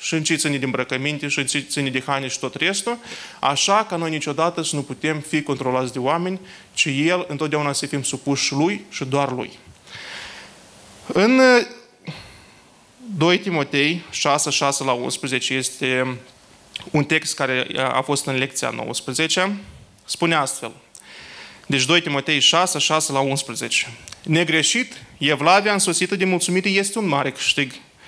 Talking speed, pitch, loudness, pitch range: 150 wpm, 145 Hz, -20 LUFS, 135-175 Hz